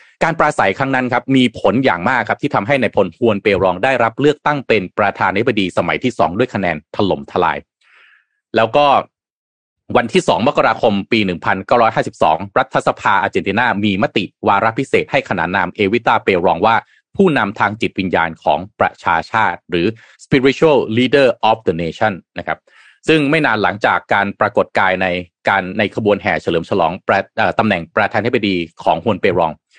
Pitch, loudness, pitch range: 105 Hz, -15 LUFS, 95-125 Hz